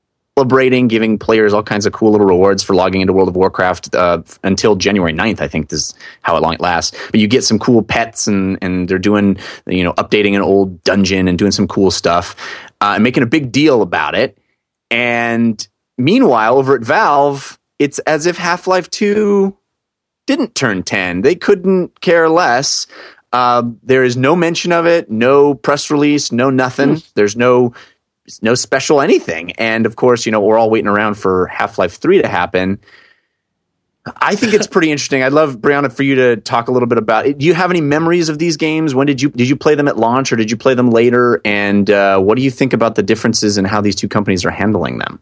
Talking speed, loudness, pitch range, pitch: 215 wpm, -13 LUFS, 100-145 Hz, 120 Hz